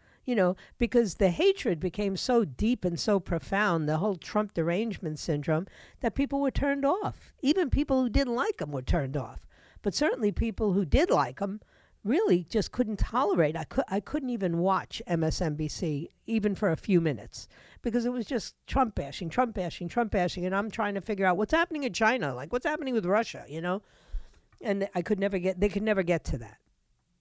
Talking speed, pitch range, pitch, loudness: 200 wpm, 175-240 Hz, 205 Hz, -29 LUFS